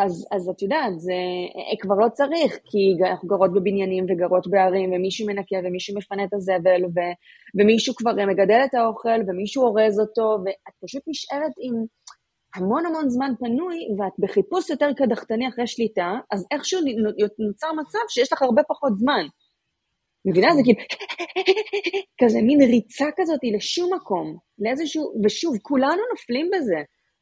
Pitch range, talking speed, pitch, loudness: 200-290 Hz, 145 wpm, 225 Hz, -22 LUFS